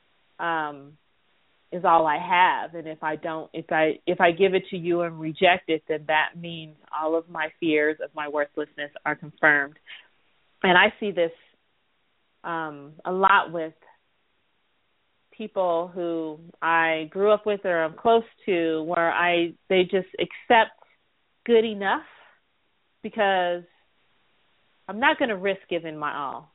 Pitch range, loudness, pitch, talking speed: 155-190 Hz, -24 LUFS, 170 Hz, 150 wpm